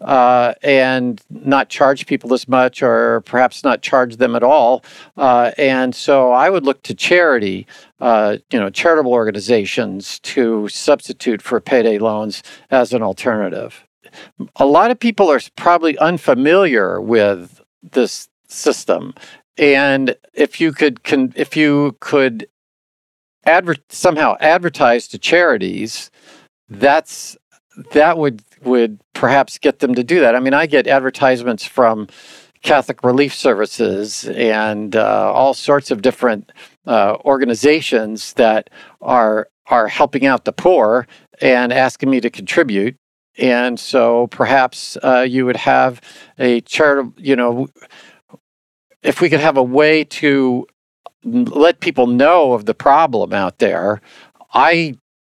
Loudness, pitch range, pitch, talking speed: -14 LUFS, 120-145 Hz, 130 Hz, 135 wpm